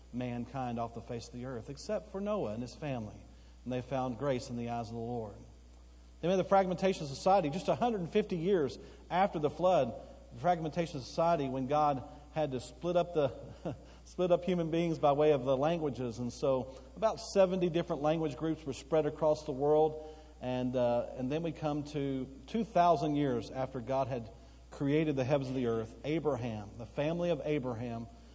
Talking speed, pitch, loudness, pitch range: 200 wpm, 145 Hz, -33 LUFS, 125-165 Hz